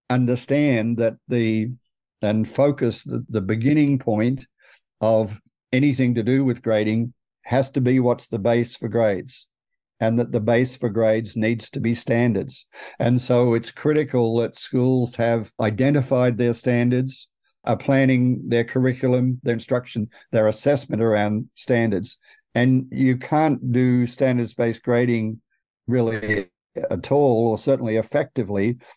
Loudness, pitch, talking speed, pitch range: -21 LUFS, 120 Hz, 135 wpm, 115-130 Hz